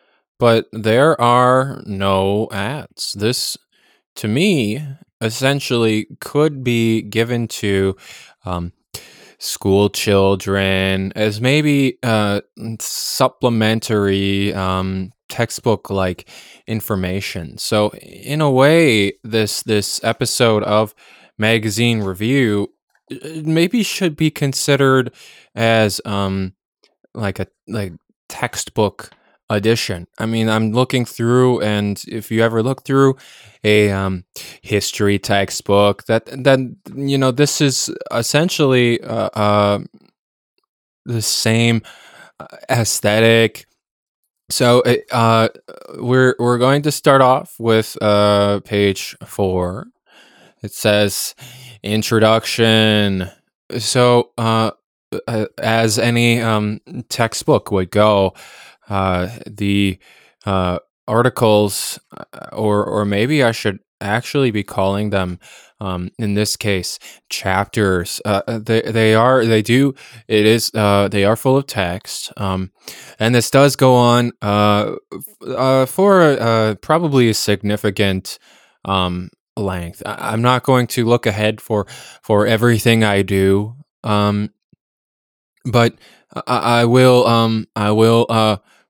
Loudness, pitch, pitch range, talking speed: -16 LUFS, 110 Hz, 100-125 Hz, 110 wpm